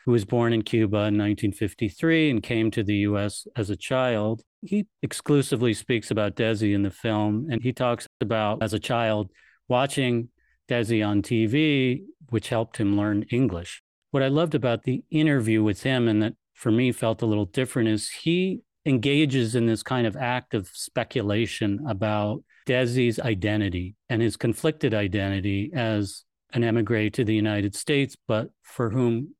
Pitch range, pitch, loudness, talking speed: 105-130 Hz, 115 Hz, -25 LUFS, 165 wpm